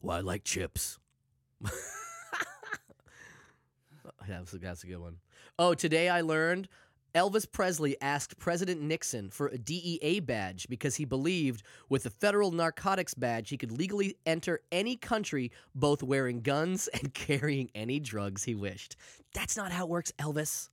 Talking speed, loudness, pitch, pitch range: 150 wpm, -33 LUFS, 150 Hz, 125-175 Hz